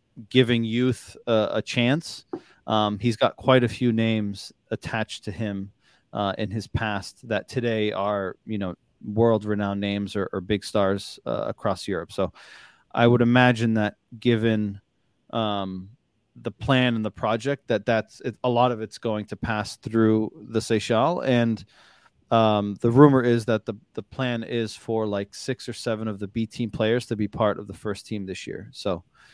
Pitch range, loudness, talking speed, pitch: 105-120 Hz, -24 LUFS, 180 wpm, 110 Hz